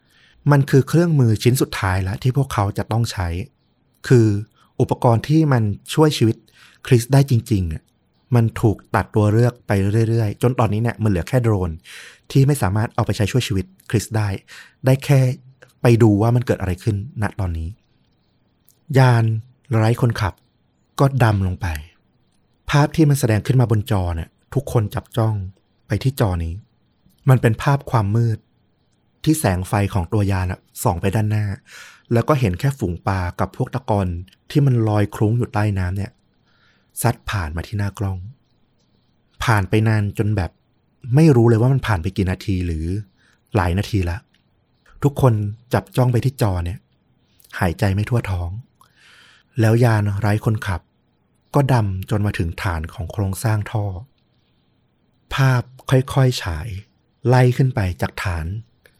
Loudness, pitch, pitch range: -19 LUFS, 110 Hz, 100-125 Hz